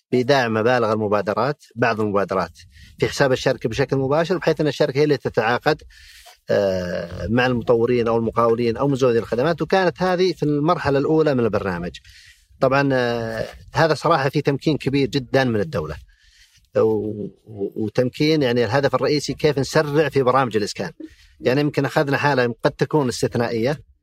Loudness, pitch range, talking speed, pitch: -20 LUFS, 110-150 Hz, 135 wpm, 135 Hz